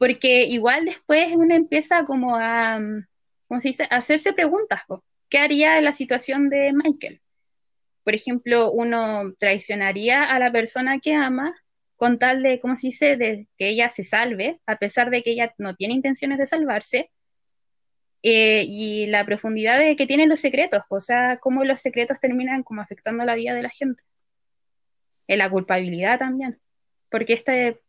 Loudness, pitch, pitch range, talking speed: -20 LUFS, 250 Hz, 220-280 Hz, 170 wpm